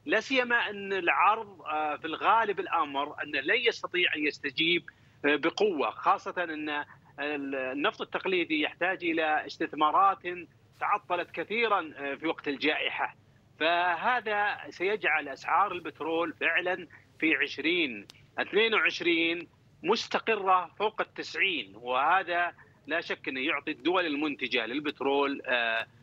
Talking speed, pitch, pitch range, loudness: 100 wpm, 170 Hz, 150-205 Hz, -29 LUFS